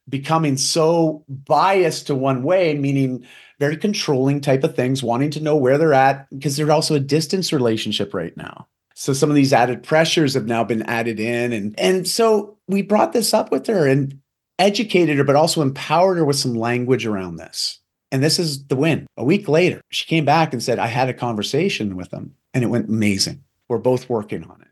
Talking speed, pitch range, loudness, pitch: 210 wpm, 125-160 Hz, -19 LUFS, 140 Hz